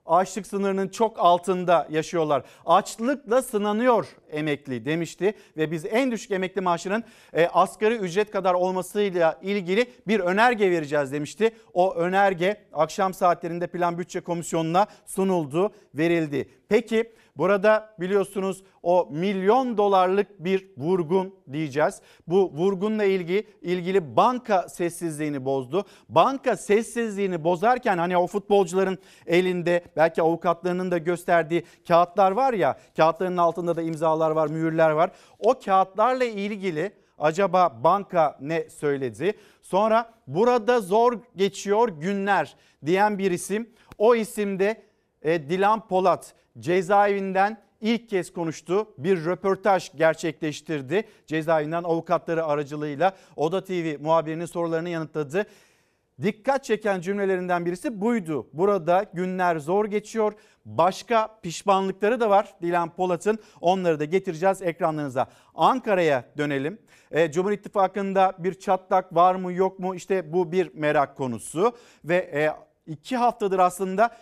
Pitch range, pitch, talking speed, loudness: 165-205 Hz, 185 Hz, 115 wpm, -24 LUFS